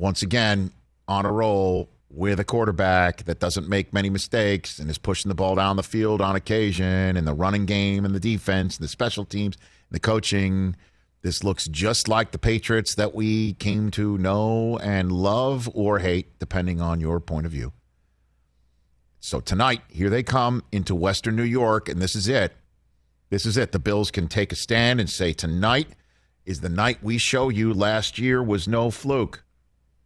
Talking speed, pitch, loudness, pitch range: 190 wpm, 100 Hz, -23 LUFS, 90-110 Hz